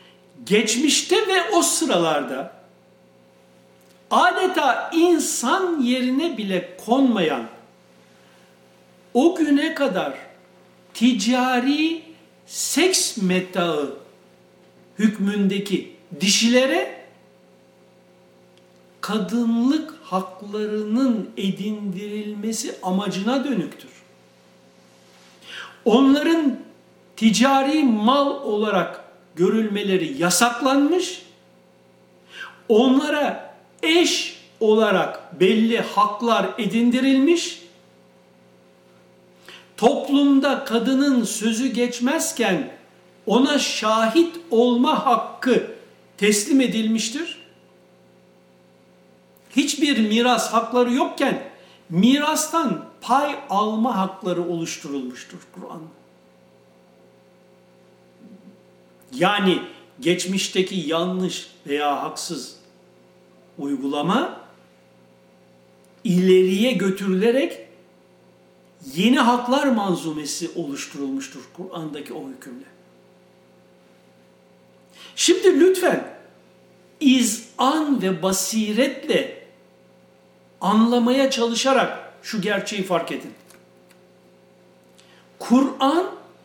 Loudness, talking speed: -20 LUFS, 55 wpm